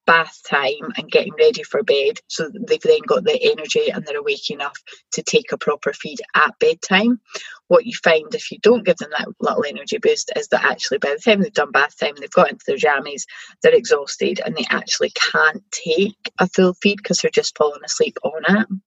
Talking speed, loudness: 225 wpm, -18 LUFS